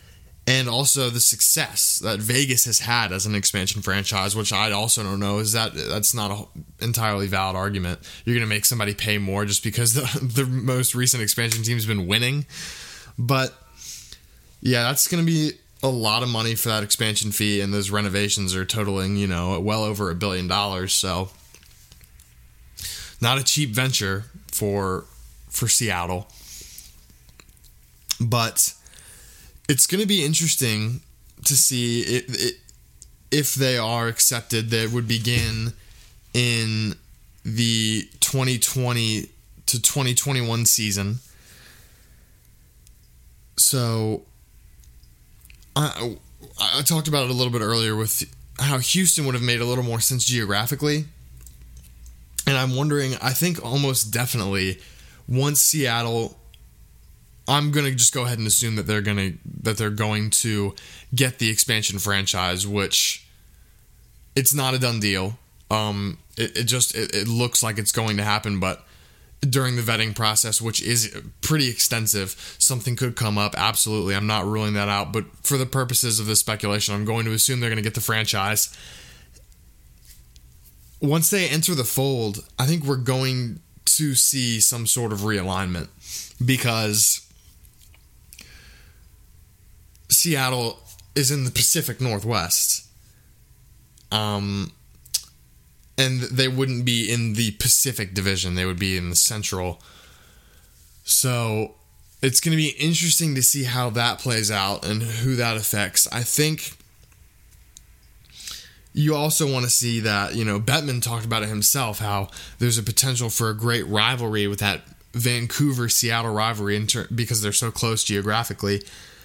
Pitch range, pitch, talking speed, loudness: 100-125 Hz, 110 Hz, 145 wpm, -21 LUFS